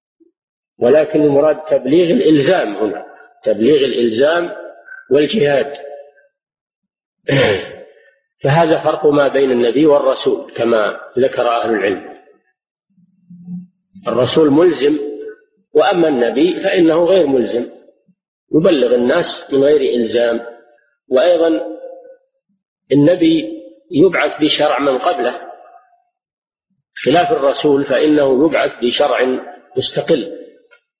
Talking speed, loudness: 80 wpm, -14 LUFS